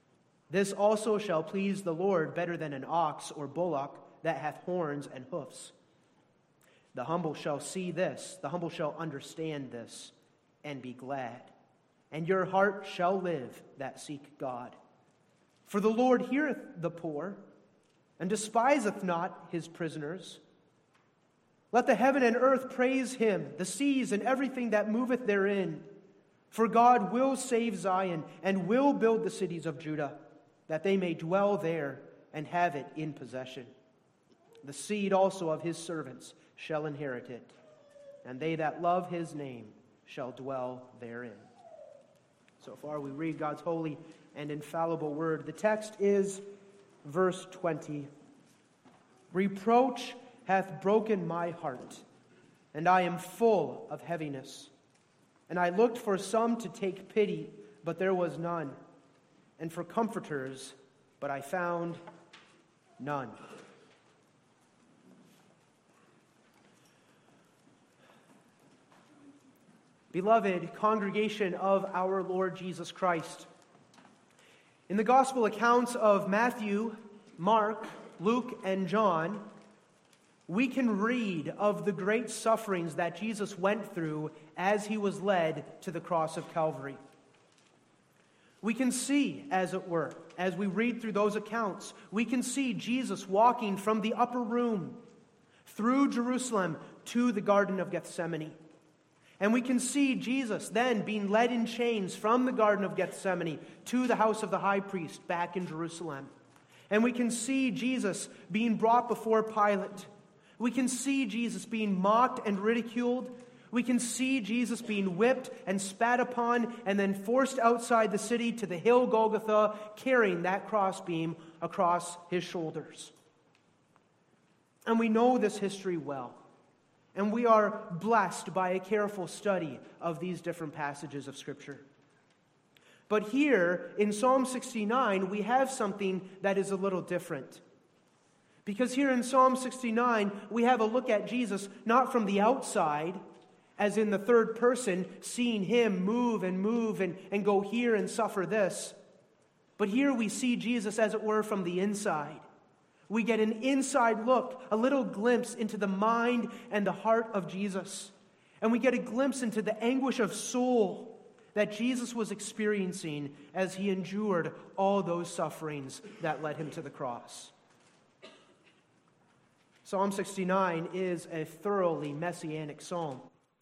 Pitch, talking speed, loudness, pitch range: 195 Hz, 140 wpm, -31 LUFS, 170-230 Hz